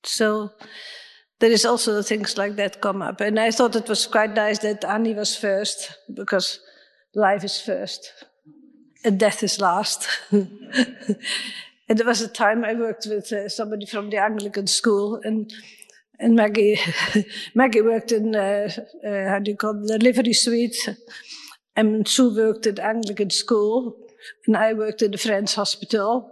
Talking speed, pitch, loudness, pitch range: 160 wpm, 215 Hz, -21 LUFS, 205-230 Hz